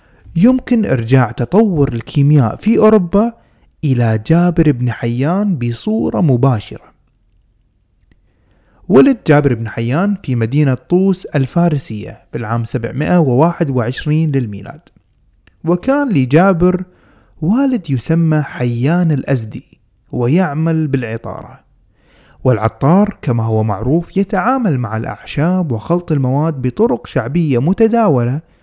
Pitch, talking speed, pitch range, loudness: 140 Hz, 90 wpm, 120-175 Hz, -14 LUFS